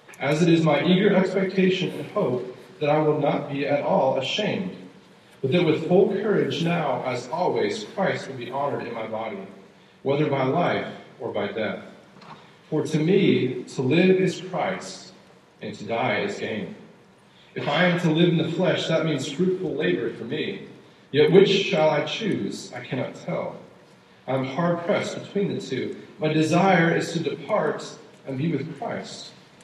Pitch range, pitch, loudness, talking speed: 150-185 Hz, 160 Hz, -24 LUFS, 175 wpm